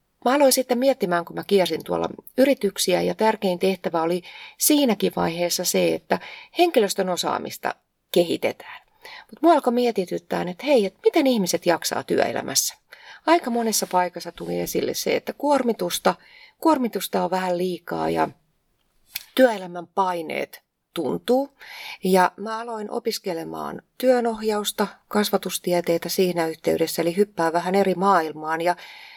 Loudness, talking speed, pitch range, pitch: -23 LUFS, 125 wpm, 175-245 Hz, 195 Hz